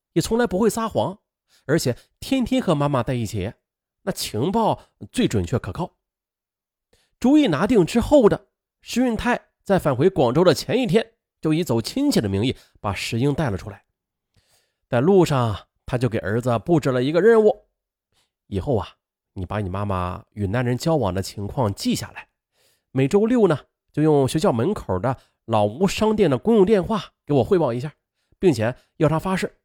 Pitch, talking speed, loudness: 155 Hz, 255 characters per minute, -21 LUFS